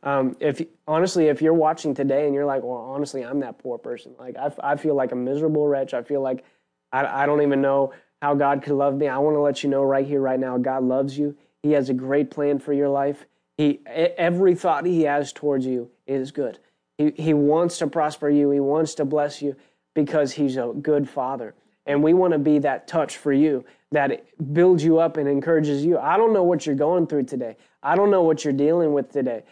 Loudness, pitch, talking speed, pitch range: -22 LUFS, 145 Hz, 235 wpm, 140-155 Hz